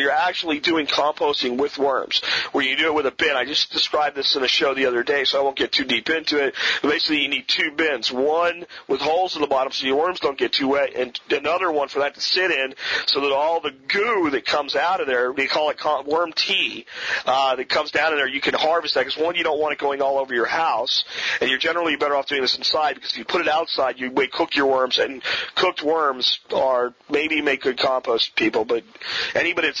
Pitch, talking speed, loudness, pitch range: 145 Hz, 250 wpm, -21 LUFS, 135-165 Hz